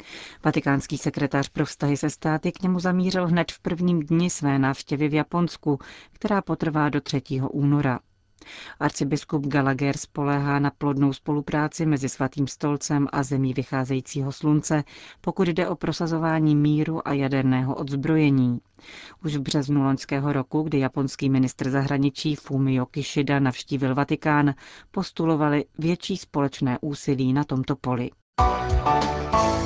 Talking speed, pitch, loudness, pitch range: 125 wpm, 145 Hz, -24 LUFS, 135-155 Hz